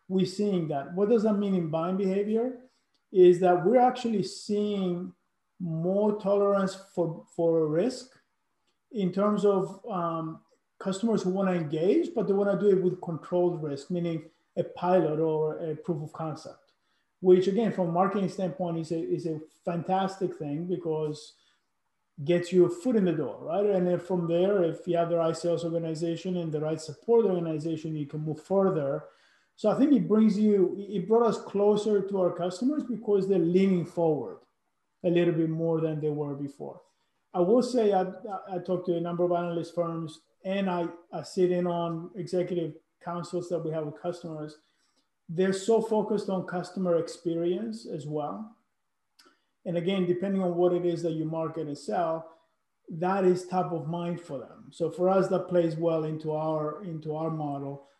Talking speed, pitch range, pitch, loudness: 180 wpm, 165-195 Hz, 175 Hz, -28 LUFS